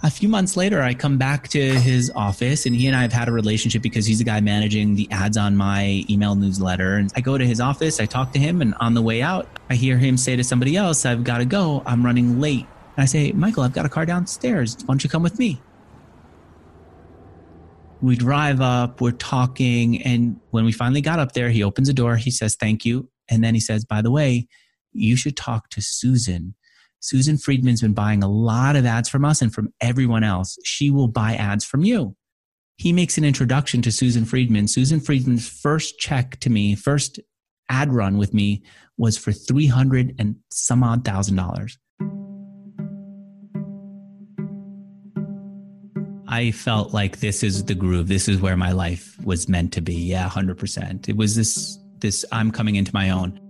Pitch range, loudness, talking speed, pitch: 105-140 Hz, -20 LUFS, 200 wpm, 120 Hz